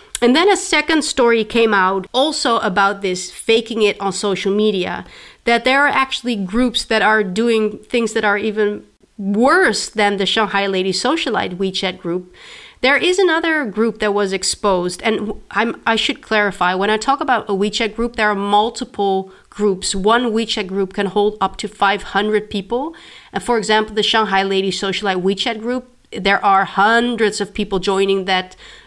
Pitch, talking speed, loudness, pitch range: 210 Hz, 175 wpm, -17 LUFS, 195-235 Hz